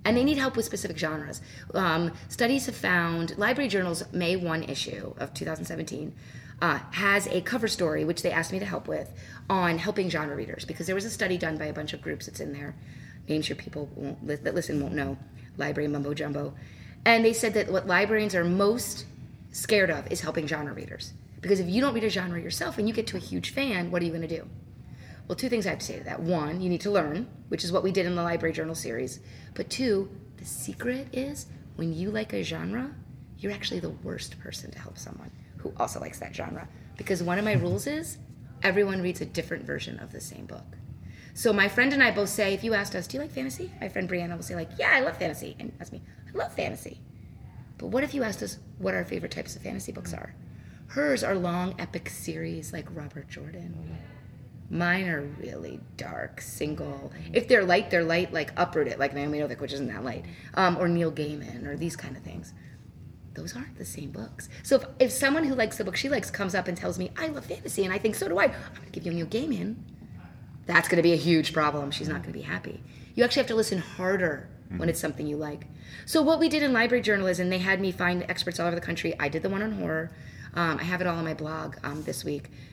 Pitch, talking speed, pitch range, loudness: 175 Hz, 240 wpm, 150-200 Hz, -28 LUFS